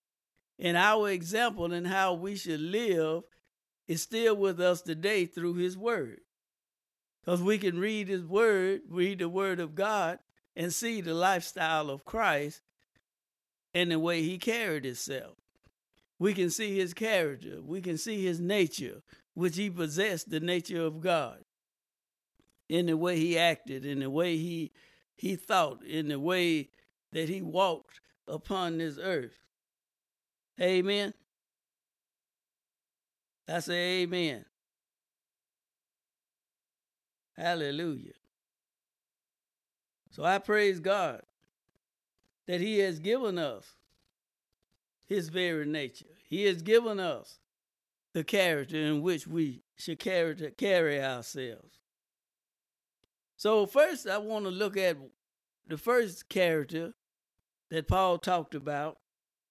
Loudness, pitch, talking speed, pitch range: -31 LUFS, 180 Hz, 120 wpm, 160-195 Hz